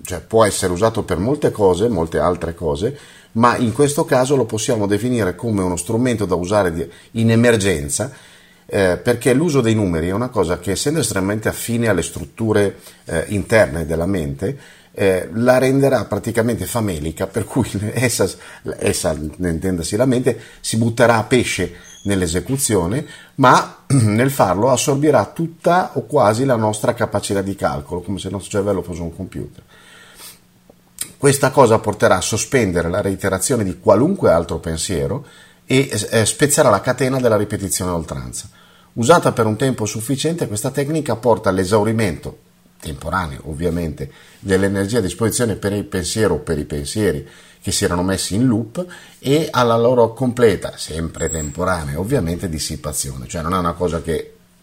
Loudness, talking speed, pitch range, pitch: -18 LUFS, 155 wpm, 90-125 Hz, 105 Hz